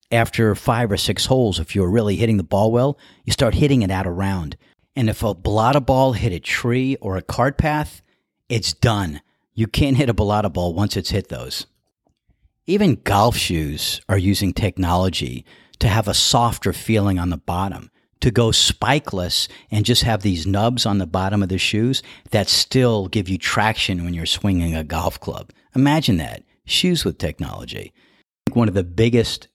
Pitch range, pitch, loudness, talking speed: 95-120 Hz, 105 Hz, -19 LUFS, 185 wpm